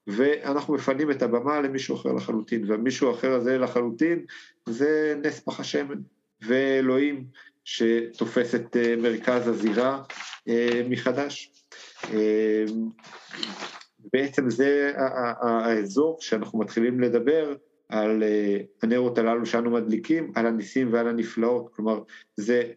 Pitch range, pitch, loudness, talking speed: 115-135 Hz, 120 Hz, -25 LUFS, 100 wpm